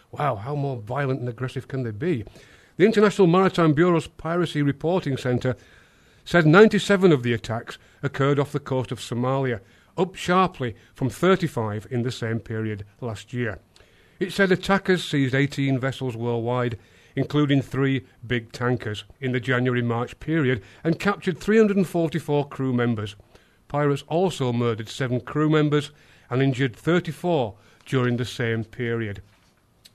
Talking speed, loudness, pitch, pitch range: 140 wpm, -23 LUFS, 130 Hz, 115-155 Hz